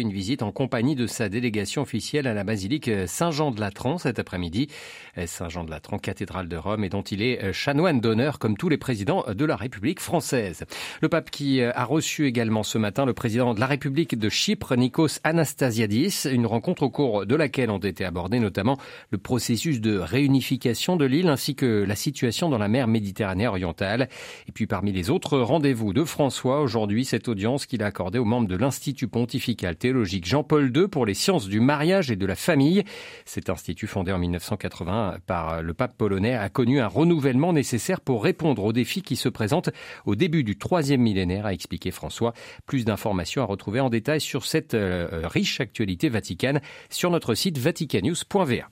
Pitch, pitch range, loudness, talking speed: 120 Hz, 105-145 Hz, -25 LUFS, 185 wpm